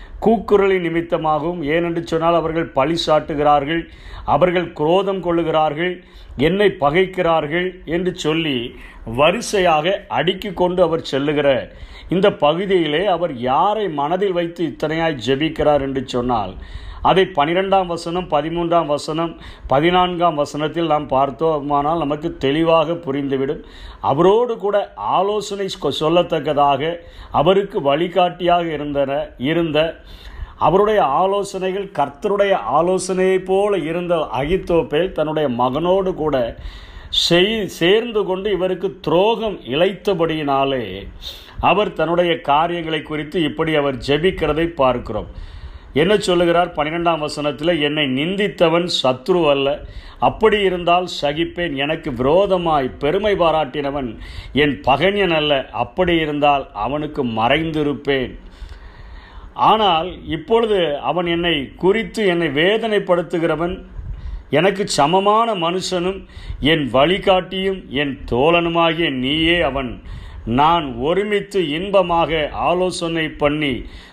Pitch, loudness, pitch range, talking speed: 165 Hz, -18 LUFS, 145-185 Hz, 95 wpm